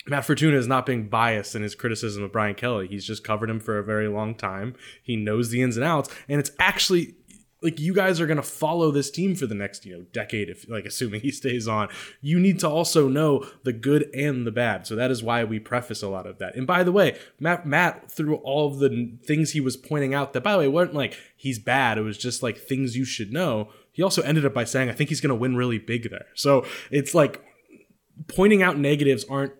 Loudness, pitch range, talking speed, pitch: -24 LUFS, 115-150 Hz, 255 wpm, 130 Hz